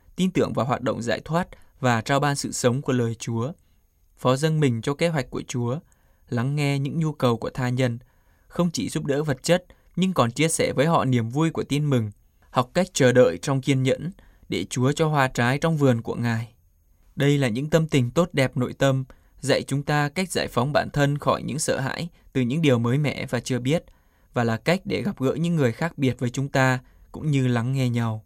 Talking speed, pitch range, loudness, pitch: 235 wpm, 120-150 Hz, -24 LUFS, 130 Hz